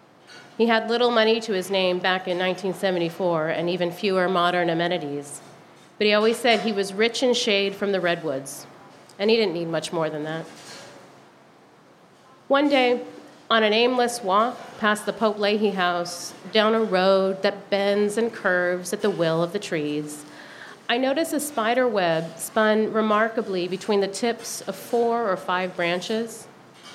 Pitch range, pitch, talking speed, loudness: 175-225 Hz, 200 Hz, 165 wpm, -23 LUFS